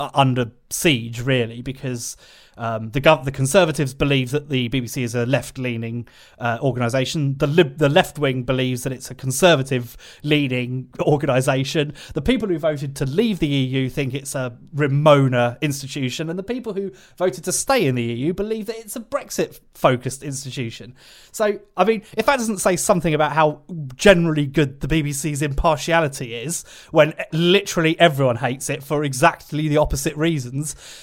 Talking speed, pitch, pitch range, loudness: 180 wpm, 145 Hz, 130-165 Hz, -20 LUFS